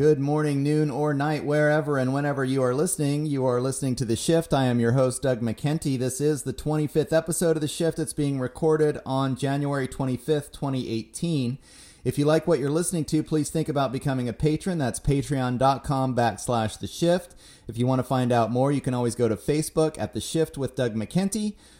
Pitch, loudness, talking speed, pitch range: 140 Hz, -25 LUFS, 205 wpm, 130-155 Hz